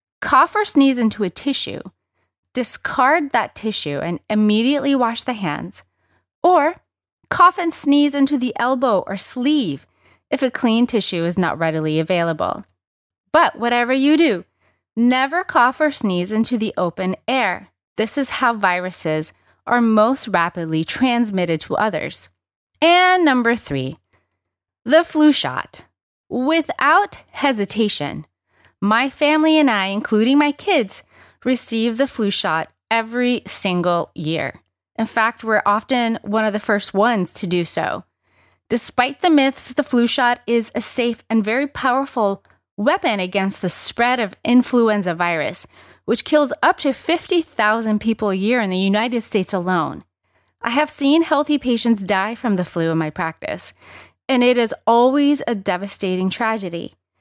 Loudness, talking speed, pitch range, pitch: -18 LUFS, 145 wpm, 190-275 Hz, 230 Hz